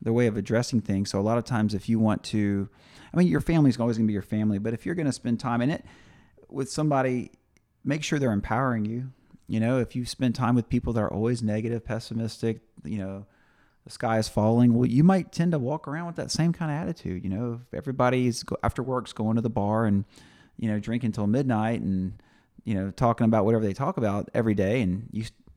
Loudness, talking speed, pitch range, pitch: -26 LUFS, 240 wpm, 110-130 Hz, 115 Hz